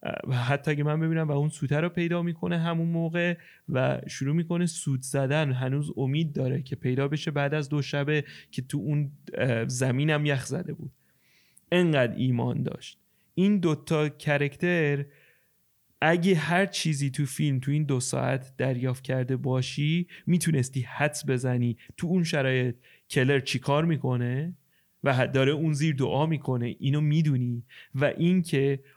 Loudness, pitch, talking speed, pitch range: -27 LUFS, 145 Hz, 145 wpm, 130-160 Hz